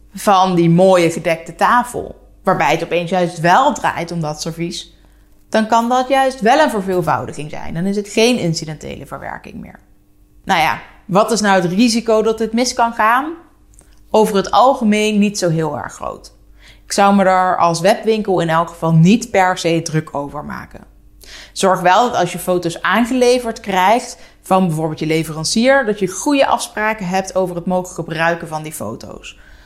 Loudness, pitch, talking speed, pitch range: -15 LUFS, 185 Hz, 180 wpm, 165-220 Hz